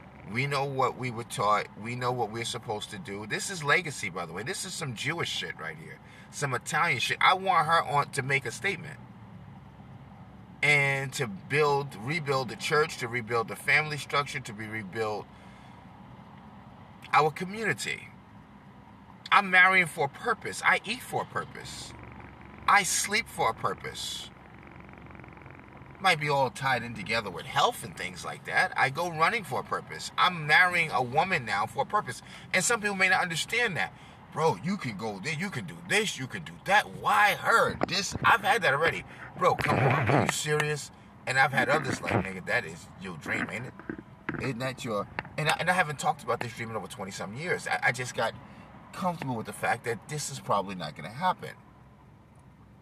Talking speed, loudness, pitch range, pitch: 195 wpm, -28 LUFS, 125-170 Hz, 145 Hz